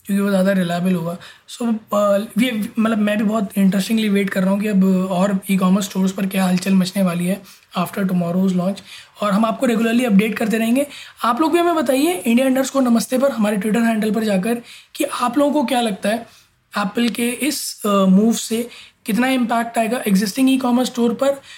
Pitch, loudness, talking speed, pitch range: 220 Hz, -18 LUFS, 205 wpm, 195-240 Hz